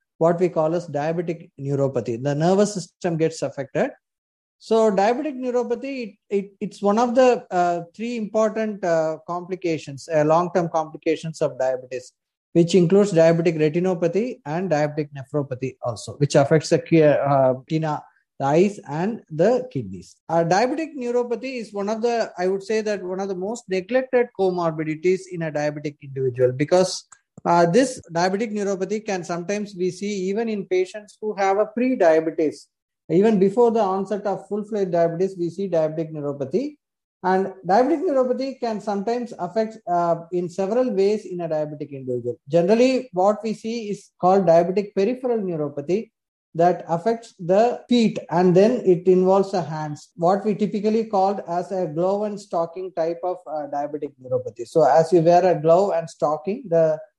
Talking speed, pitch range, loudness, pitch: 160 wpm, 160-210 Hz, -22 LUFS, 185 Hz